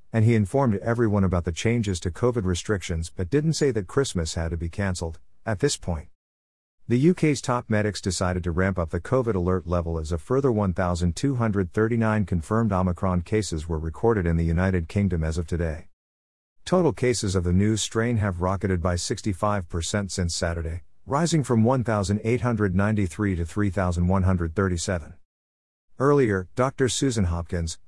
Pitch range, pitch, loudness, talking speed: 85-115 Hz, 95 Hz, -25 LUFS, 155 wpm